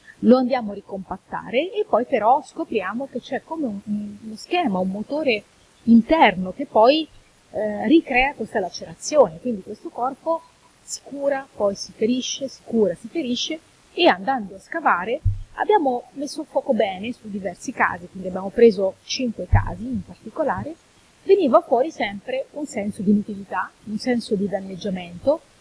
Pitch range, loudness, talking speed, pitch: 205-275 Hz, -22 LUFS, 150 wpm, 235 Hz